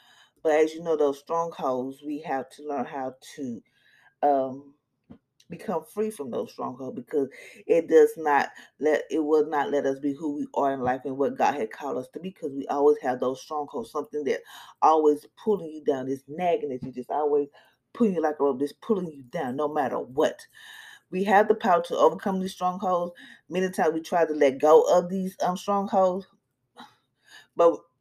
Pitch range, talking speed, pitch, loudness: 140-185 Hz, 195 wpm, 155 Hz, -26 LUFS